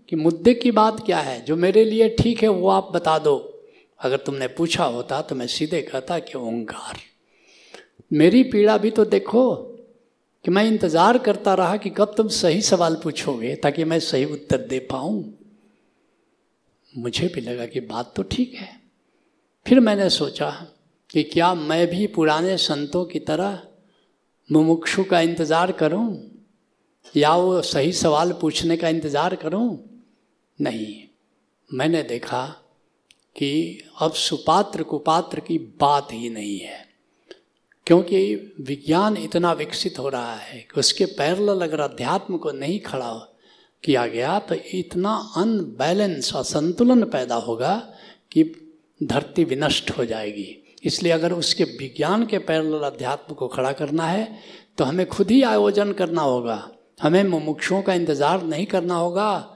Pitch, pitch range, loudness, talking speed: 170 Hz, 150-205 Hz, -21 LUFS, 145 wpm